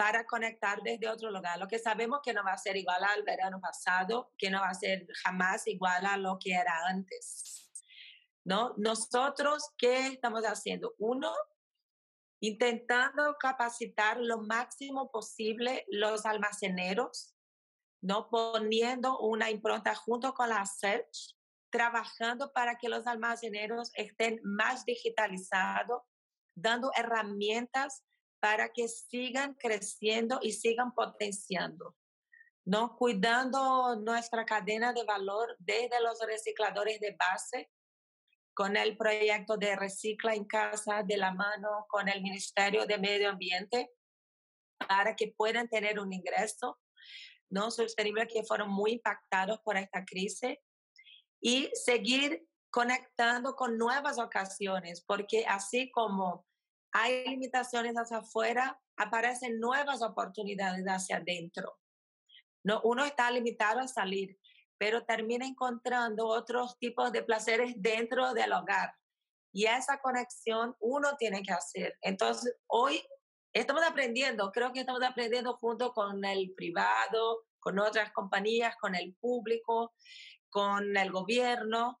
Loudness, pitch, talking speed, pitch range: -33 LUFS, 230 Hz, 125 wpm, 210-245 Hz